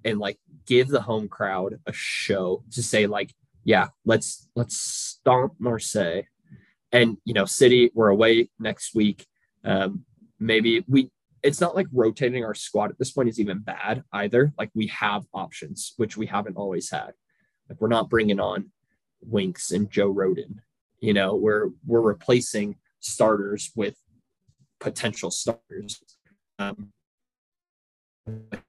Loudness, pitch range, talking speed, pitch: -24 LUFS, 100-120 Hz, 140 wpm, 110 Hz